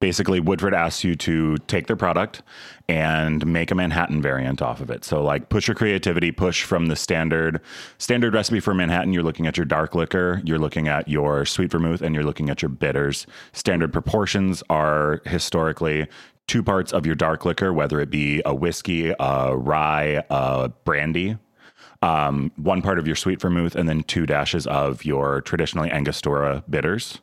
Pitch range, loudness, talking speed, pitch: 75-90 Hz, -22 LUFS, 180 wpm, 80 Hz